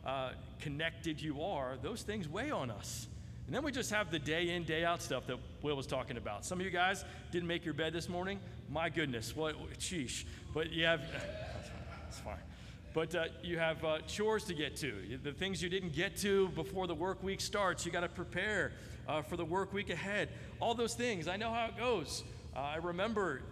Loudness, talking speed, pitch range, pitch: -38 LUFS, 225 wpm, 150-190 Hz, 170 Hz